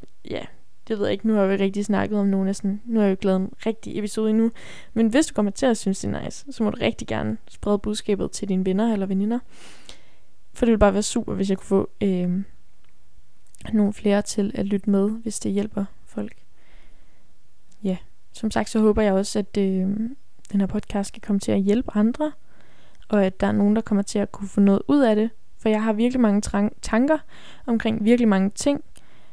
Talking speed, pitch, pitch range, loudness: 230 wpm, 205 Hz, 195-220 Hz, -23 LUFS